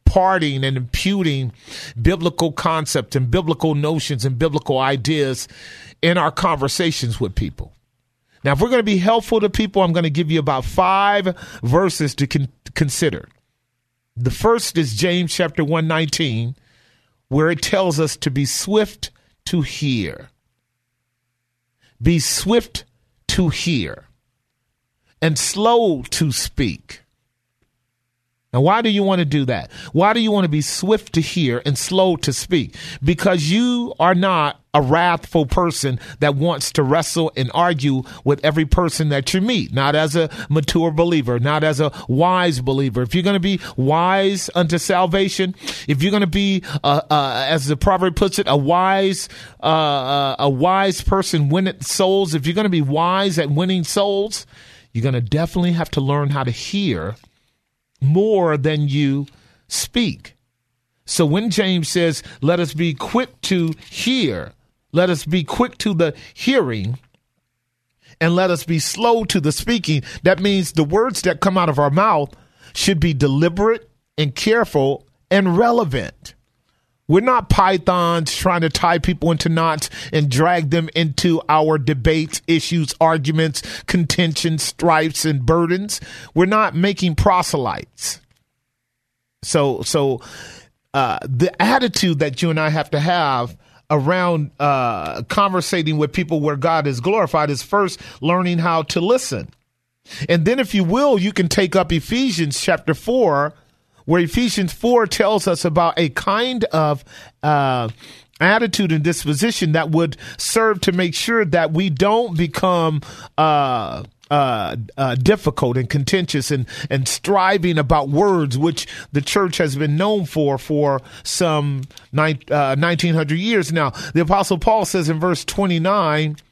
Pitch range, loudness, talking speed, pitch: 140-185 Hz, -18 LUFS, 155 wpm, 160 Hz